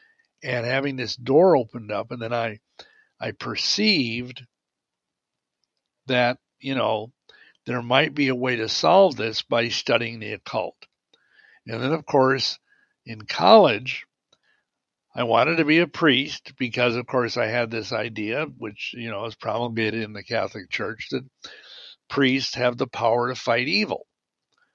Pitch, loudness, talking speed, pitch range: 125 Hz, -23 LUFS, 150 wpm, 115-135 Hz